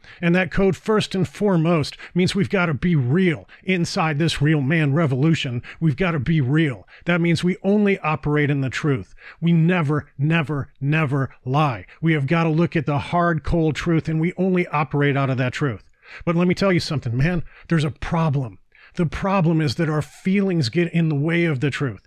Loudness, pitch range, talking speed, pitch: -21 LUFS, 145-175 Hz, 205 wpm, 160 Hz